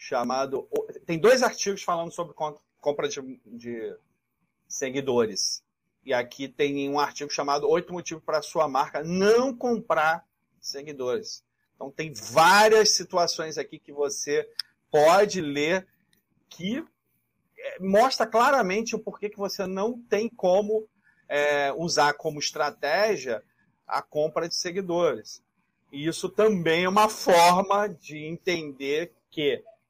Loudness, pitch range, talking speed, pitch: -25 LUFS, 150-215 Hz, 120 wpm, 175 Hz